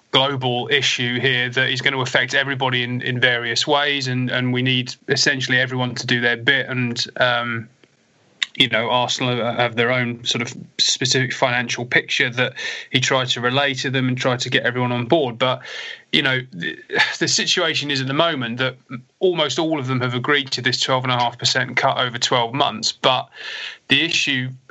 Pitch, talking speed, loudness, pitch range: 130 Hz, 185 wpm, -19 LUFS, 125-135 Hz